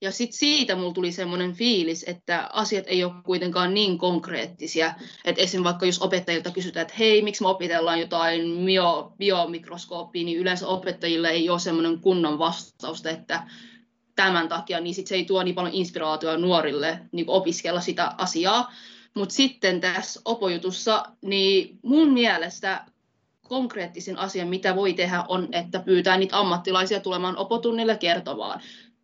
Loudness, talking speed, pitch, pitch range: -24 LUFS, 145 wpm, 185 Hz, 170-195 Hz